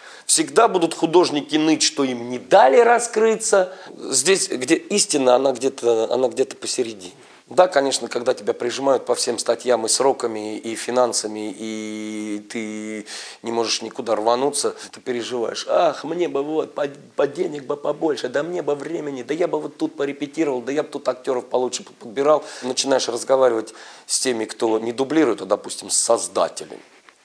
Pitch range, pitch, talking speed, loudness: 115-165 Hz, 135 Hz, 165 wpm, -20 LUFS